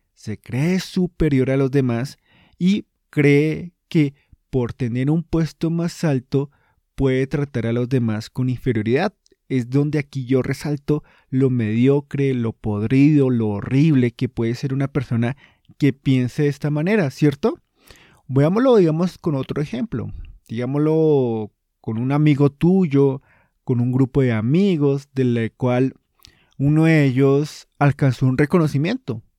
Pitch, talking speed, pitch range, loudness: 135 Hz, 135 wpm, 125-150 Hz, -20 LUFS